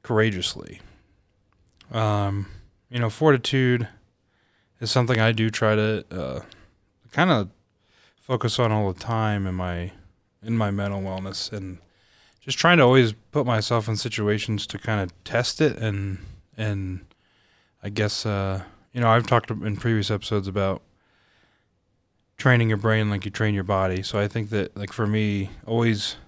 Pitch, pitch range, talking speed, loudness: 105 Hz, 100-115 Hz, 155 wpm, -24 LUFS